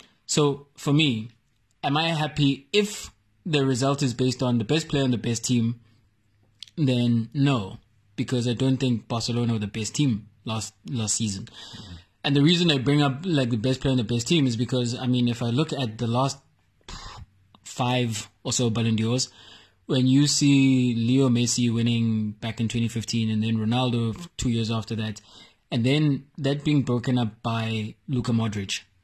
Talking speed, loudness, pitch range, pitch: 180 wpm, -24 LUFS, 110-135 Hz, 120 Hz